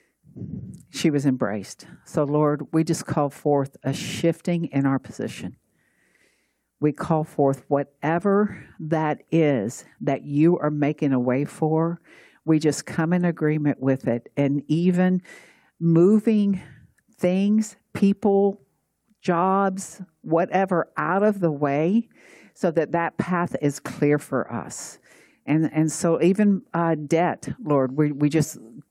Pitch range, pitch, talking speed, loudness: 145-180 Hz, 160 Hz, 130 wpm, -23 LUFS